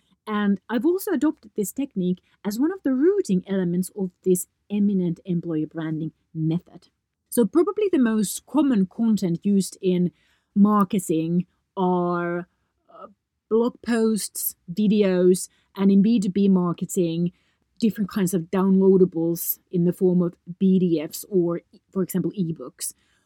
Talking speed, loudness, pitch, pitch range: 125 wpm, -23 LUFS, 190 Hz, 175-210 Hz